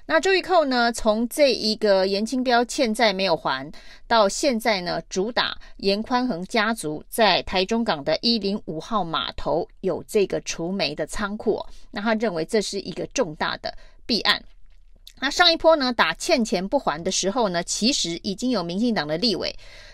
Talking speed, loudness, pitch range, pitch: 255 characters per minute, -22 LUFS, 190-245 Hz, 220 Hz